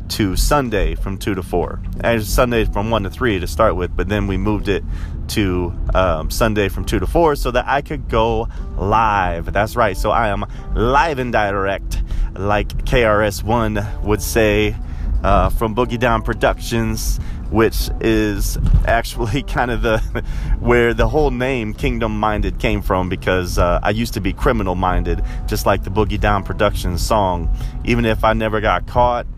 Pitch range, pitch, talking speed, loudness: 90-115 Hz, 105 Hz, 175 wpm, -18 LUFS